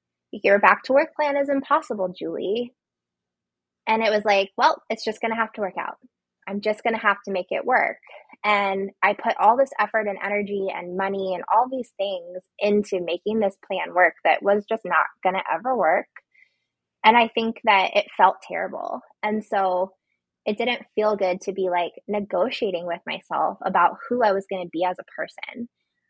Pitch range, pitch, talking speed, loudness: 185-230 Hz, 205 Hz, 200 wpm, -23 LUFS